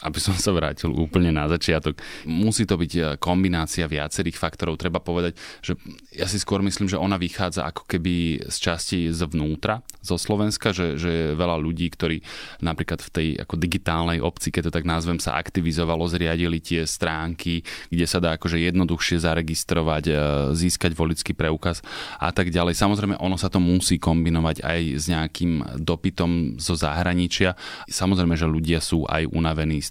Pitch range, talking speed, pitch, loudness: 80-90 Hz, 165 wpm, 85 Hz, -24 LUFS